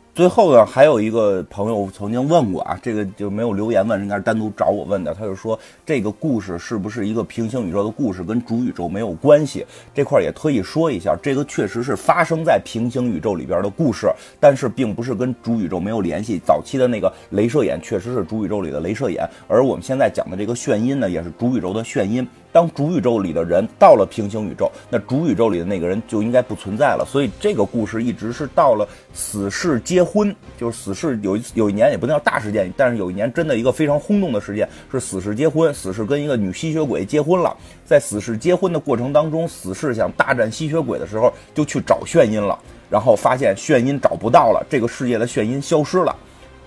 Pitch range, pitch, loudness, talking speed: 105-150 Hz, 120 Hz, -19 LUFS, 355 characters per minute